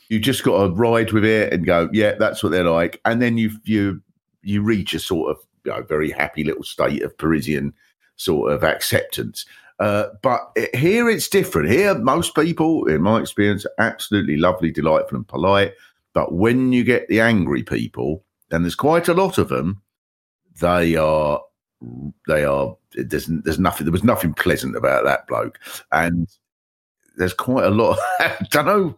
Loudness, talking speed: -19 LUFS, 185 wpm